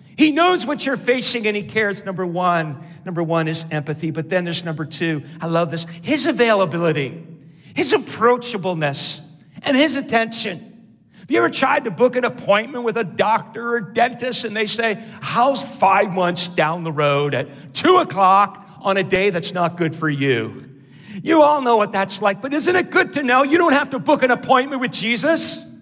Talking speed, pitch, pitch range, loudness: 195 wpm, 205 Hz, 165-250 Hz, -18 LUFS